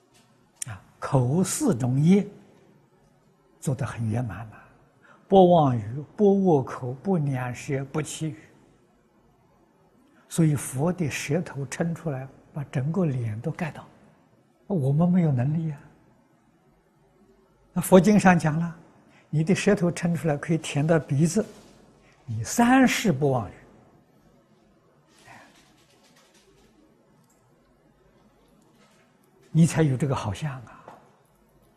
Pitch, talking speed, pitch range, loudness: 155 Hz, 145 characters per minute, 135-175 Hz, -24 LUFS